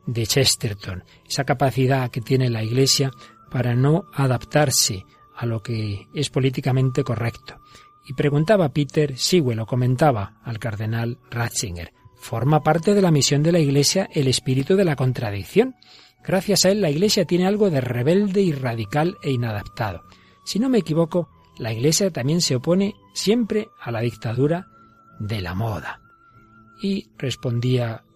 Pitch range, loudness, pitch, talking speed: 120-170 Hz, -21 LUFS, 135 Hz, 155 wpm